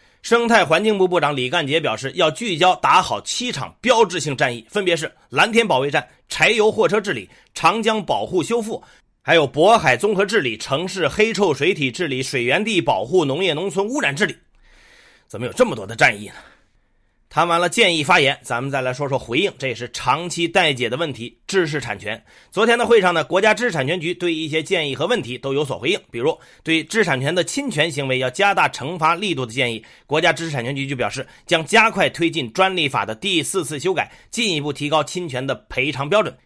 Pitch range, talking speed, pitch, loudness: 135-205 Hz, 325 characters per minute, 165 Hz, -19 LUFS